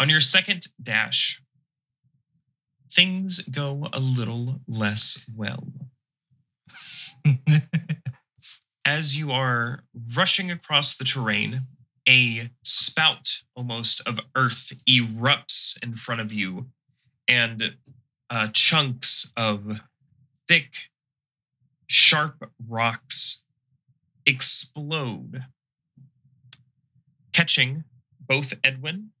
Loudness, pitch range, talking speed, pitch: -19 LUFS, 125-145 Hz, 80 wpm, 135 Hz